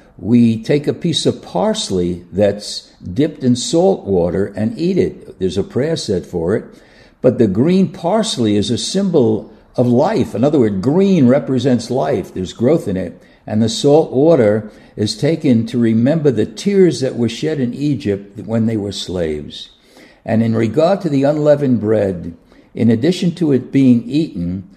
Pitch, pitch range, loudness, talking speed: 120 Hz, 105-150 Hz, -16 LUFS, 170 wpm